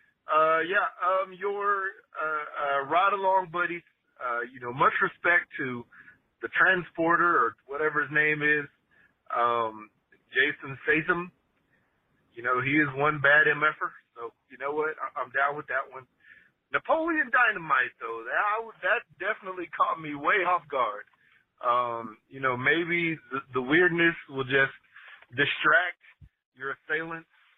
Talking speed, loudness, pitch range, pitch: 140 wpm, -26 LUFS, 135-180 Hz, 155 Hz